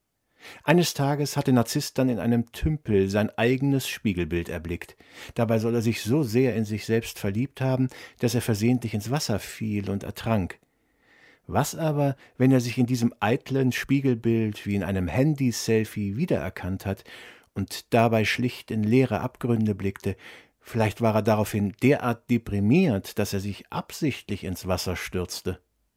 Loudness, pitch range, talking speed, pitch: -26 LUFS, 100-130 Hz, 155 wpm, 115 Hz